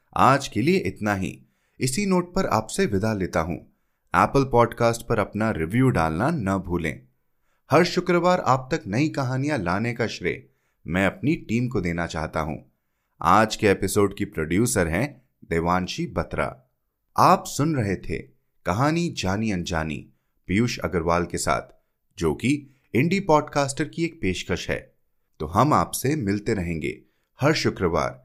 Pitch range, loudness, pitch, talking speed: 85-140 Hz, -24 LUFS, 110 Hz, 135 wpm